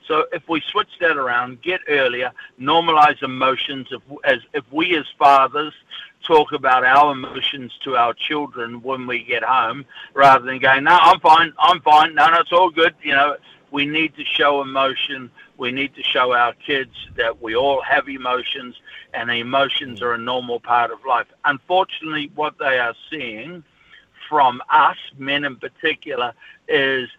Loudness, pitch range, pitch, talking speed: -18 LUFS, 125-150 Hz, 140 Hz, 170 wpm